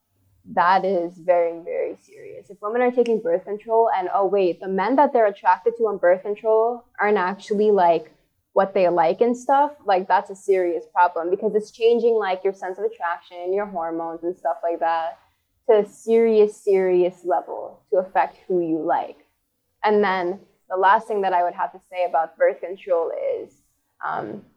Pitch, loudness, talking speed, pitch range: 195 Hz, -21 LUFS, 185 wpm, 175-225 Hz